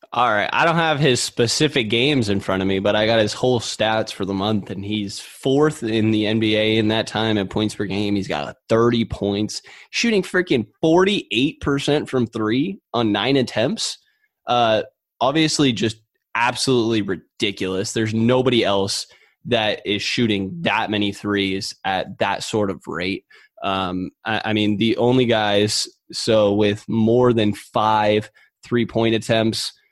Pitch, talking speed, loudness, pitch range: 110 Hz, 160 wpm, -20 LUFS, 105-125 Hz